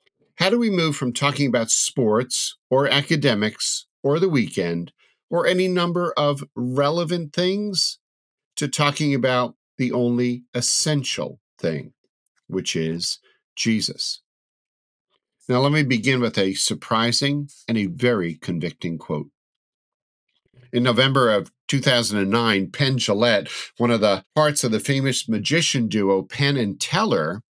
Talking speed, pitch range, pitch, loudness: 130 wpm, 115-145 Hz, 130 Hz, -21 LUFS